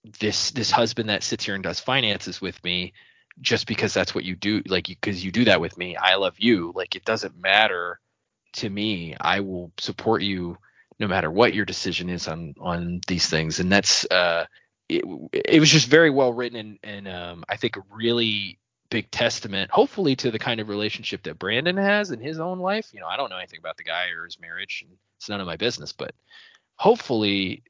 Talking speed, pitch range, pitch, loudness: 215 wpm, 95-125 Hz, 105 Hz, -23 LUFS